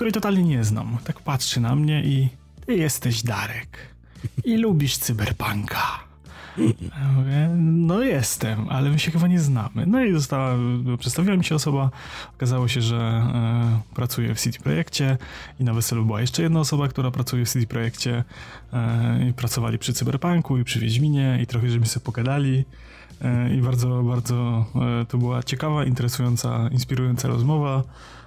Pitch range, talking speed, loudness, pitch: 120-140 Hz, 160 wpm, -23 LUFS, 125 Hz